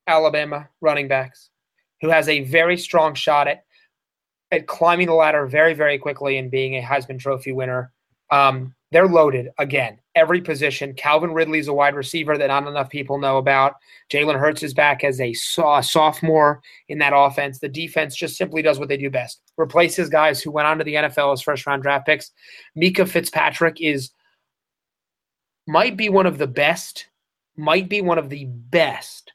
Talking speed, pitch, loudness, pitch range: 180 wpm, 150 Hz, -19 LUFS, 140-160 Hz